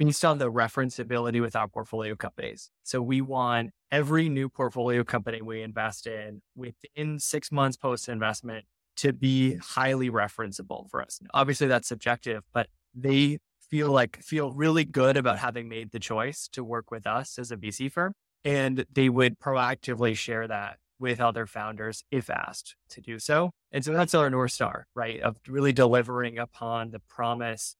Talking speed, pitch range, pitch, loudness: 170 wpm, 115-135 Hz, 125 Hz, -28 LUFS